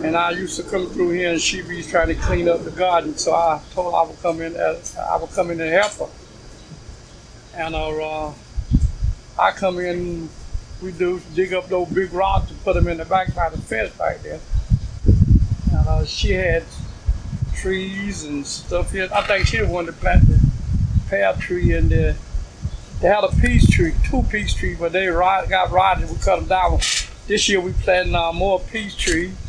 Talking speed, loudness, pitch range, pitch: 205 wpm, -20 LUFS, 125-180 Hz, 170 Hz